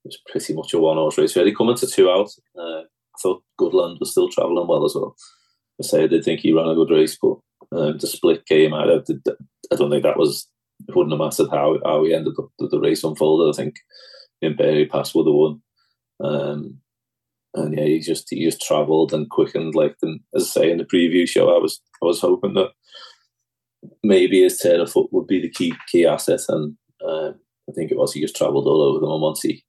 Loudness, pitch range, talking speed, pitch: -19 LUFS, 365-420 Hz, 240 wpm, 385 Hz